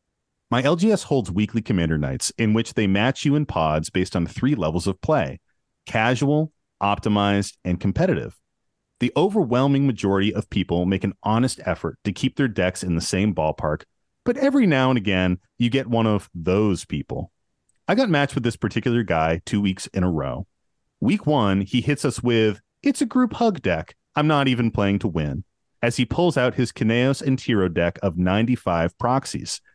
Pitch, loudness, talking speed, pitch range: 110 Hz, -22 LUFS, 185 wpm, 95-135 Hz